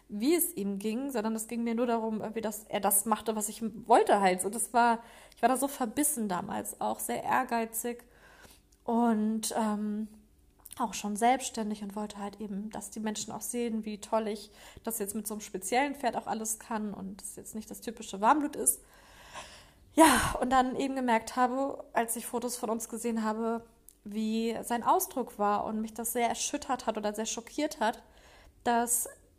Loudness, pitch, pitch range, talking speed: -31 LUFS, 225 Hz, 215-240 Hz, 190 wpm